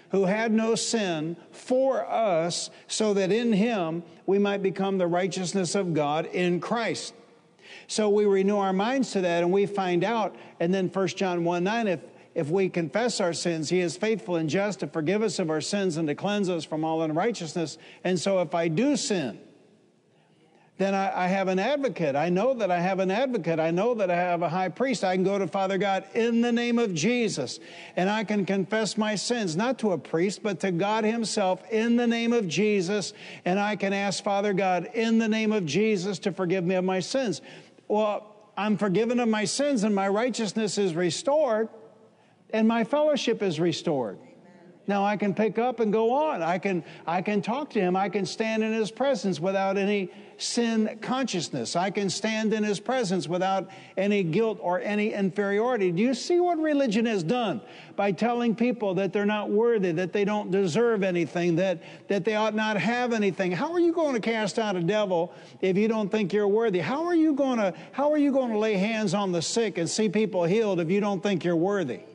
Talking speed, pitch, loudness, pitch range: 210 wpm, 200 Hz, -26 LUFS, 185-220 Hz